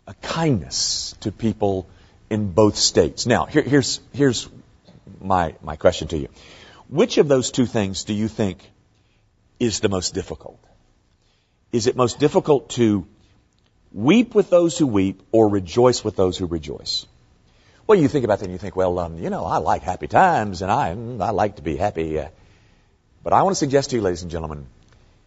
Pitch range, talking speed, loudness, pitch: 95-125 Hz, 185 wpm, -20 LUFS, 105 Hz